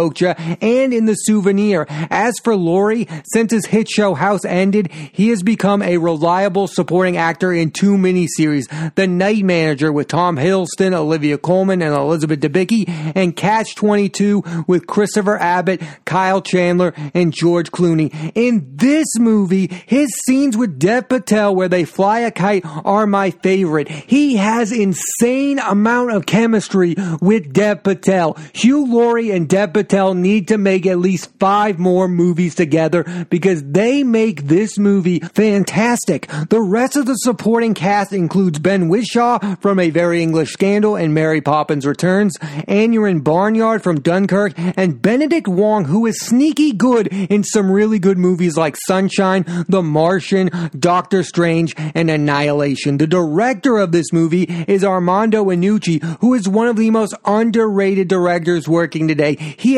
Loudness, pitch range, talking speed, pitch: -15 LUFS, 170-210 Hz, 150 wpm, 190 Hz